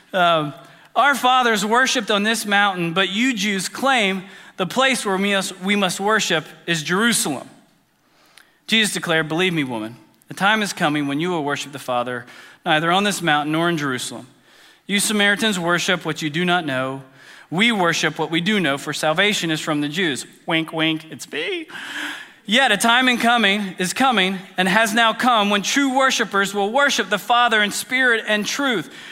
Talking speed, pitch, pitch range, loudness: 180 wpm, 195 Hz, 160-220 Hz, -19 LUFS